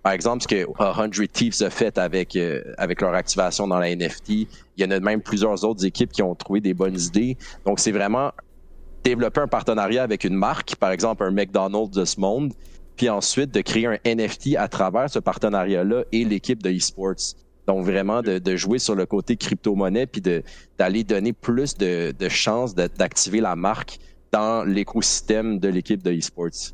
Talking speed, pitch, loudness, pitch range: 195 wpm, 100 Hz, -22 LUFS, 90-110 Hz